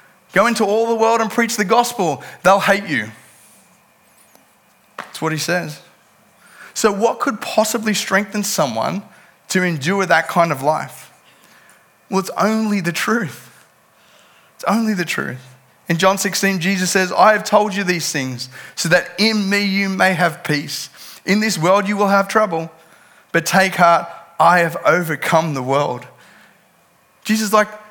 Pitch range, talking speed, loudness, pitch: 170-215 Hz, 160 wpm, -17 LUFS, 195 Hz